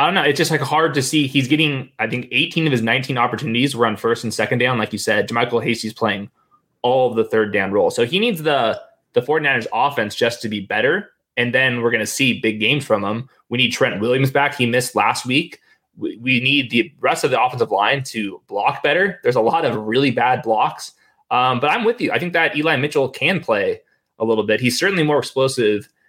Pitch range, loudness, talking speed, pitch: 115-150 Hz, -18 LUFS, 235 wpm, 125 Hz